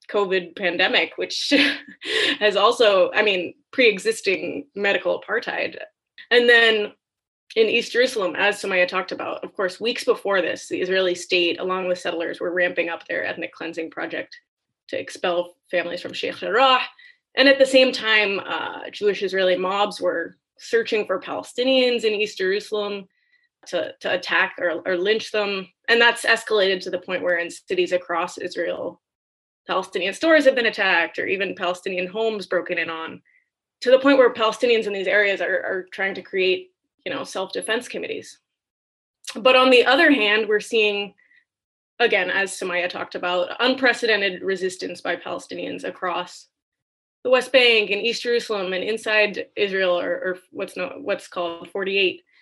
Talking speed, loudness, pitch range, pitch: 160 wpm, -21 LUFS, 185-255 Hz, 210 Hz